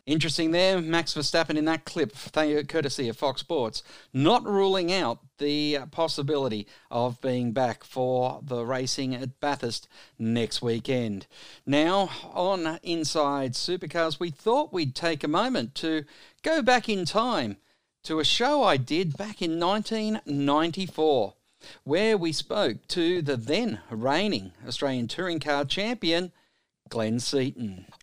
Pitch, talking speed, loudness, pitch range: 150 Hz, 135 wpm, -27 LUFS, 130-175 Hz